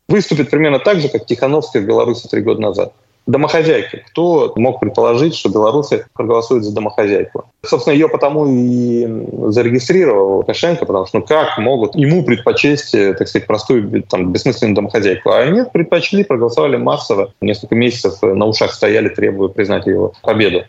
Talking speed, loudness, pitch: 155 wpm, -14 LUFS, 150 Hz